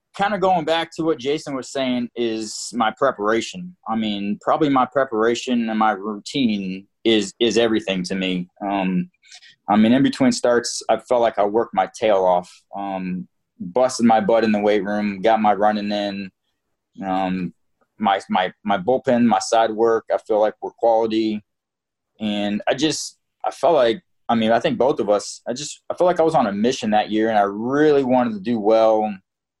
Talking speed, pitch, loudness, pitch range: 195 wpm, 110 Hz, -20 LUFS, 105-125 Hz